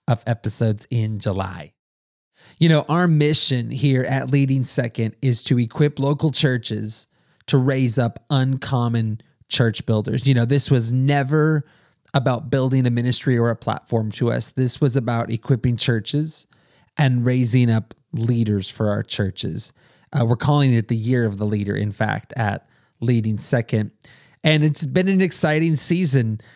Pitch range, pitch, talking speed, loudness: 115-140 Hz, 125 Hz, 155 wpm, -20 LUFS